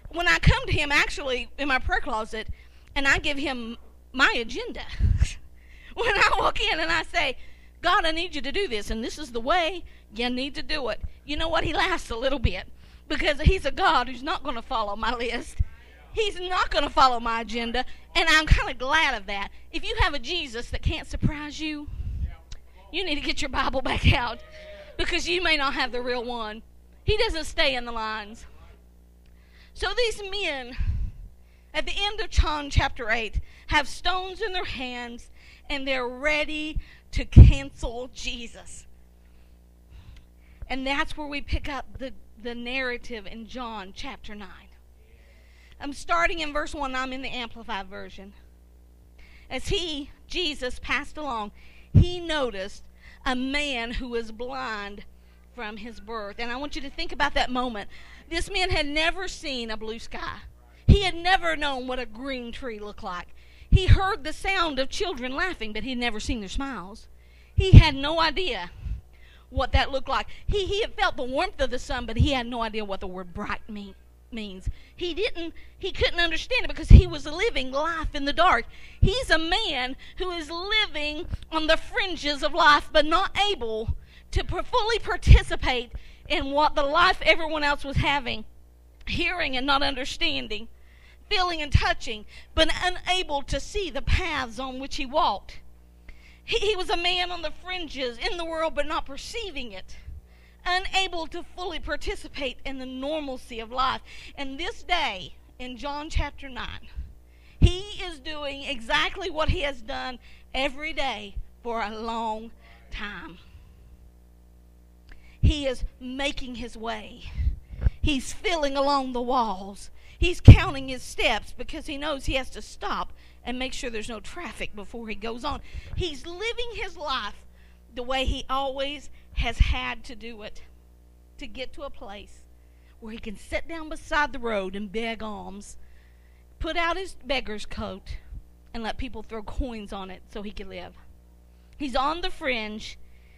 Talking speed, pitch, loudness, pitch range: 175 wpm, 260 Hz, -26 LUFS, 210-315 Hz